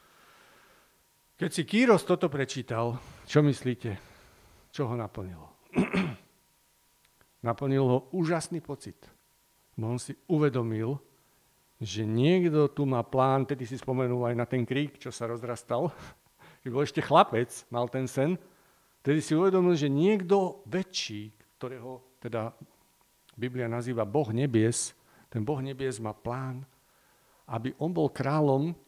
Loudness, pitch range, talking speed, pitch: -29 LUFS, 120-150 Hz, 125 wpm, 130 Hz